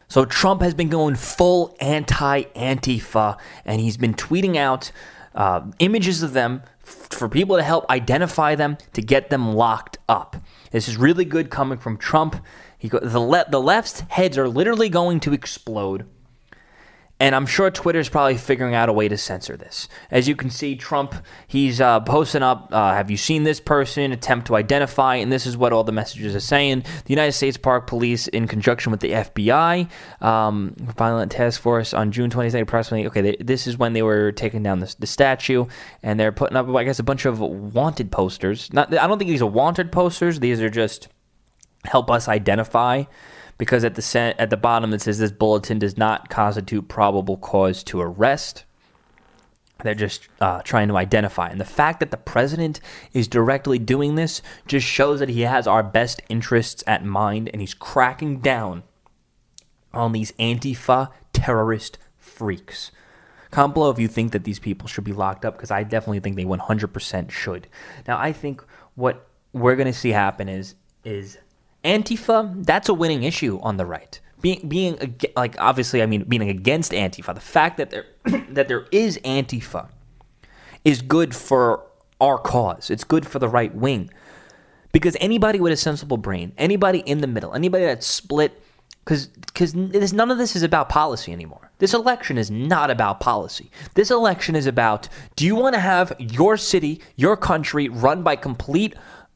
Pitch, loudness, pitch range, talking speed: 125 Hz, -20 LUFS, 110-150 Hz, 185 wpm